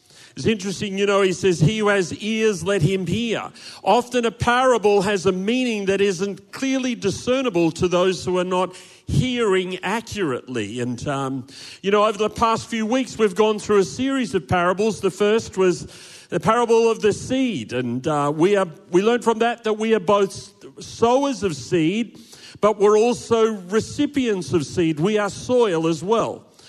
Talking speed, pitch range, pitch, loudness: 180 wpm, 180-225 Hz, 205 Hz, -21 LUFS